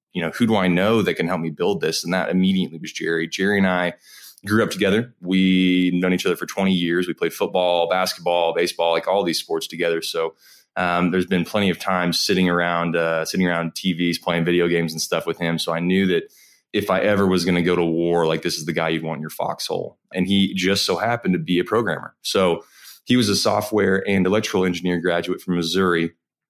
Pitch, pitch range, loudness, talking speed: 90 Hz, 85-95 Hz, -21 LUFS, 235 wpm